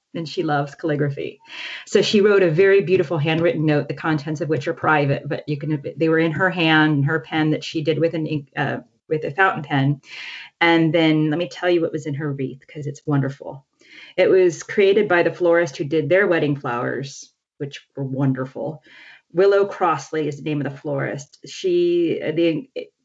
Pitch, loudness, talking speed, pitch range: 160 Hz, -20 LUFS, 205 wpm, 150-175 Hz